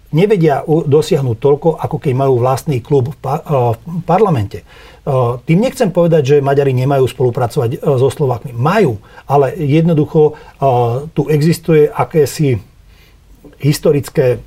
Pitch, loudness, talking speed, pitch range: 145 Hz, -13 LUFS, 110 wpm, 125-155 Hz